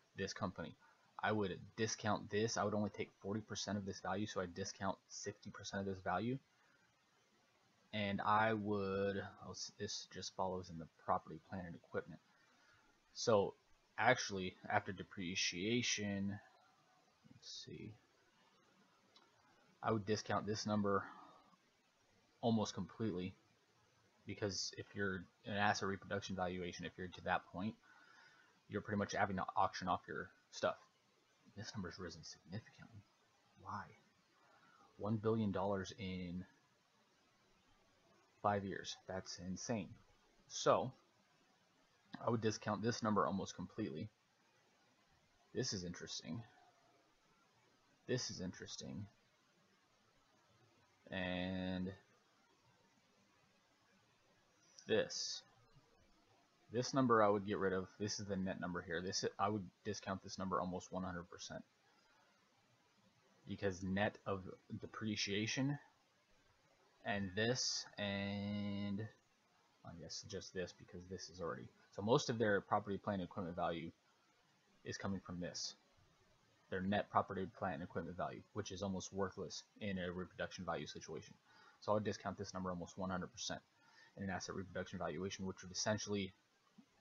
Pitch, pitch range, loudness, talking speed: 100 Hz, 95-105 Hz, -42 LUFS, 125 wpm